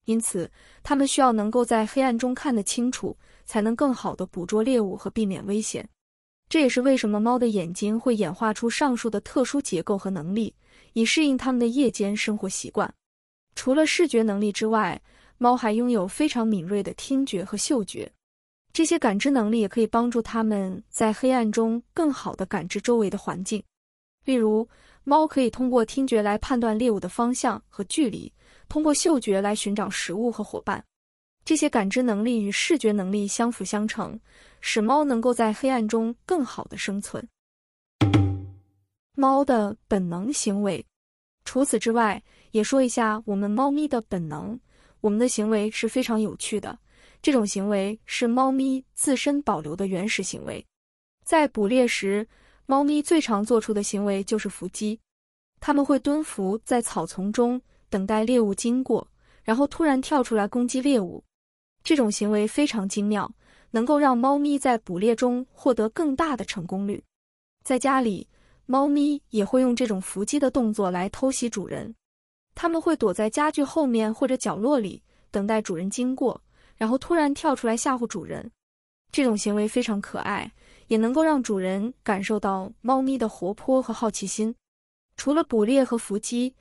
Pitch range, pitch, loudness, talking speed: 205-265 Hz, 230 Hz, -24 LUFS, 260 characters per minute